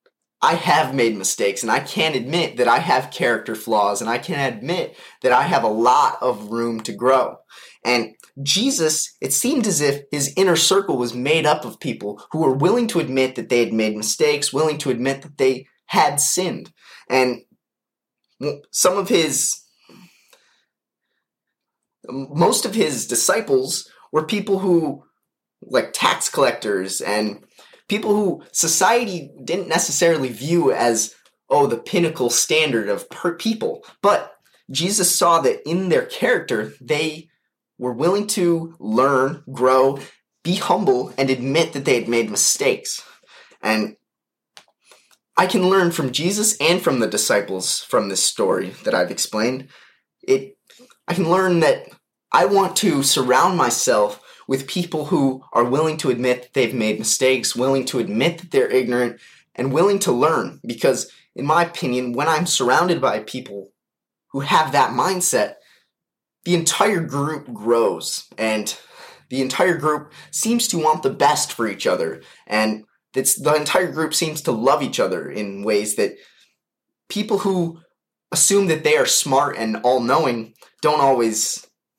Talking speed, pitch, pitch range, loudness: 150 wpm, 155 Hz, 130-185 Hz, -19 LUFS